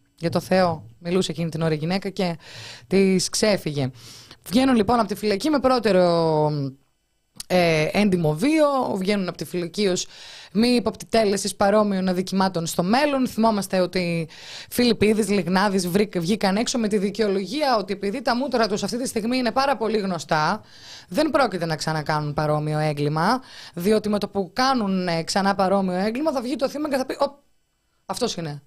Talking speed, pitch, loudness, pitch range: 165 wpm, 195 Hz, -22 LUFS, 170-225 Hz